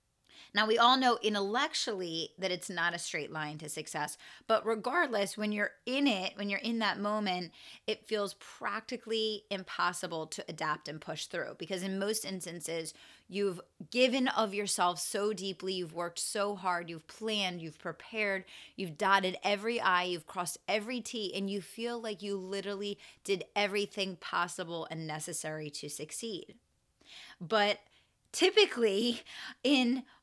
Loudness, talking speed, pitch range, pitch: -33 LUFS, 150 wpm, 175-220 Hz, 200 Hz